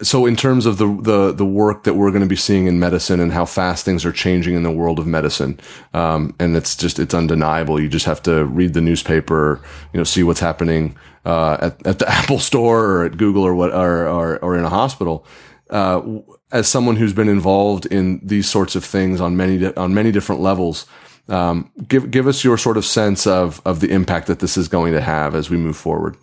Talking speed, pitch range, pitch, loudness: 230 wpm, 85-100 Hz, 90 Hz, -17 LUFS